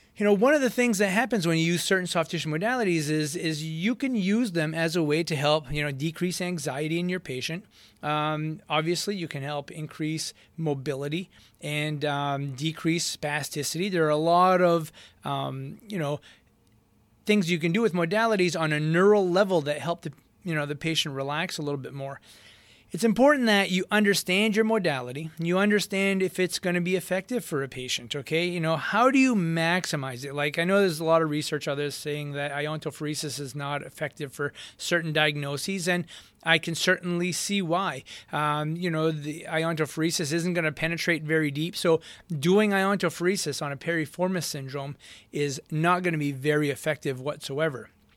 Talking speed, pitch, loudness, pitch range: 190 wpm, 160 Hz, -26 LUFS, 150-180 Hz